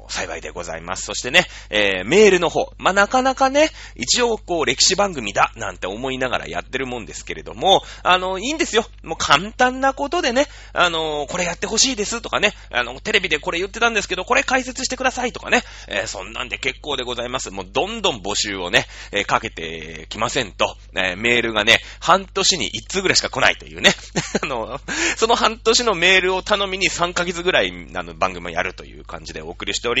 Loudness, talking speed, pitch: -19 LUFS, 430 characters per minute, 185 Hz